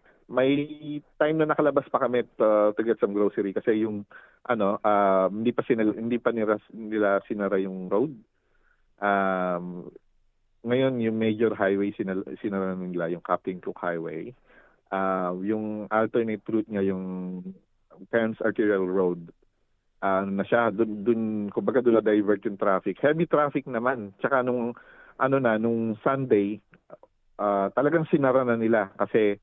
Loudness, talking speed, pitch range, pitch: -26 LUFS, 145 wpm, 100-120 Hz, 110 Hz